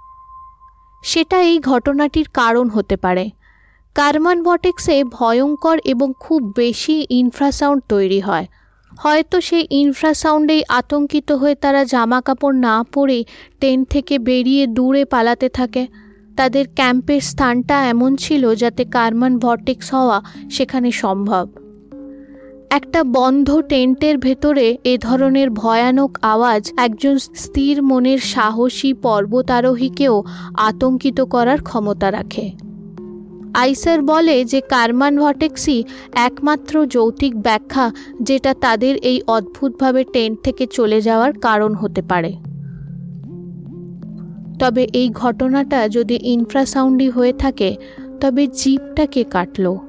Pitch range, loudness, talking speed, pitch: 230-280 Hz, -16 LUFS, 105 wpm, 255 Hz